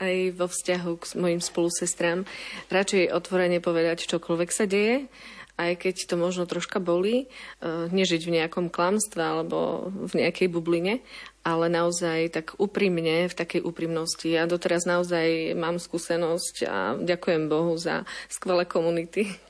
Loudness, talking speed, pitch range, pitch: -26 LUFS, 135 wpm, 170-185 Hz, 175 Hz